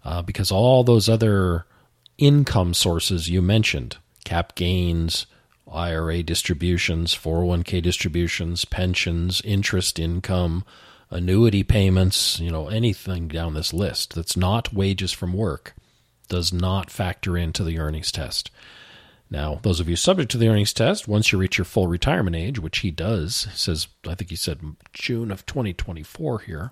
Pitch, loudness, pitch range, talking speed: 90 Hz, -22 LUFS, 85-105 Hz, 150 wpm